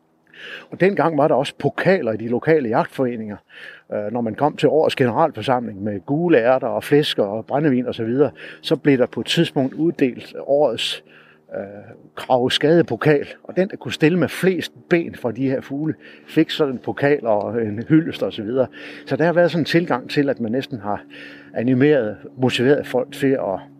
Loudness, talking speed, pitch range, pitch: -20 LUFS, 190 wpm, 115-155 Hz, 135 Hz